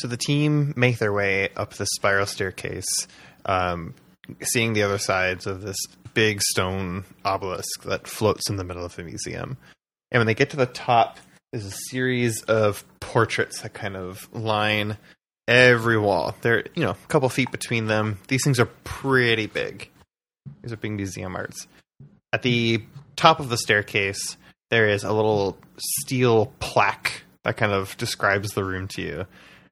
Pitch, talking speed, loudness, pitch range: 110 Hz, 170 wpm, -23 LUFS, 100-125 Hz